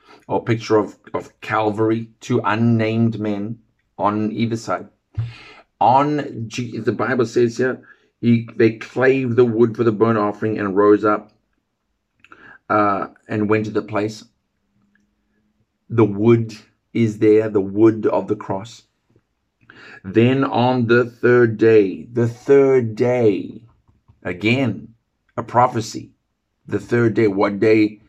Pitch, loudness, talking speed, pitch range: 110 Hz, -18 LUFS, 125 wpm, 105-120 Hz